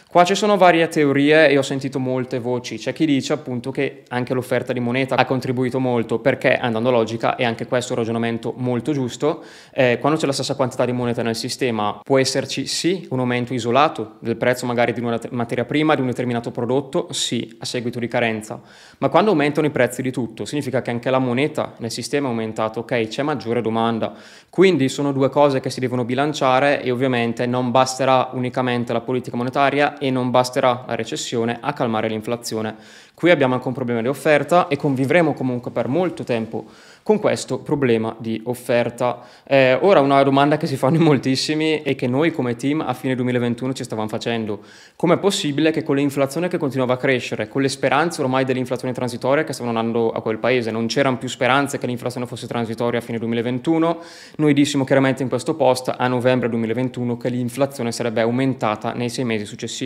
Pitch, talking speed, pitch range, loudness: 130 Hz, 195 wpm, 120-140 Hz, -20 LUFS